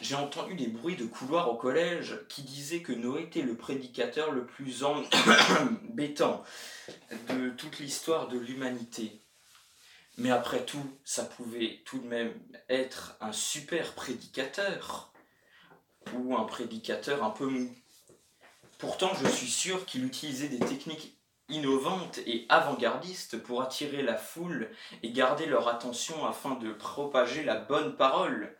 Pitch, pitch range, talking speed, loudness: 135 Hz, 120-155 Hz, 140 wpm, -31 LUFS